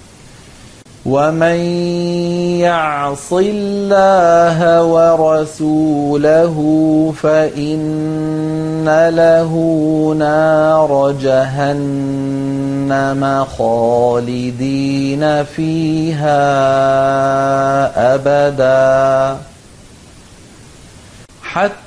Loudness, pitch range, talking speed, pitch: -13 LUFS, 135-160 Hz, 30 wpm, 155 Hz